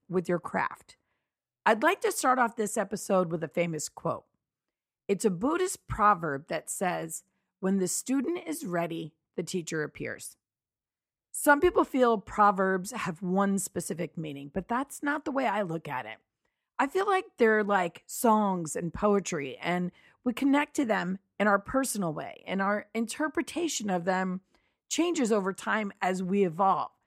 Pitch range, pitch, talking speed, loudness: 180-255 Hz, 200 Hz, 160 wpm, -29 LUFS